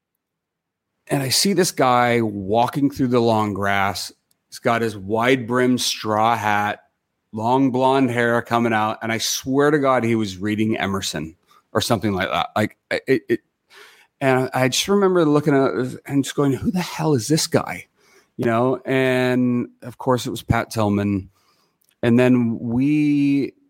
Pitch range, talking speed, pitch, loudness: 115-135 Hz, 165 wpm, 125 Hz, -20 LUFS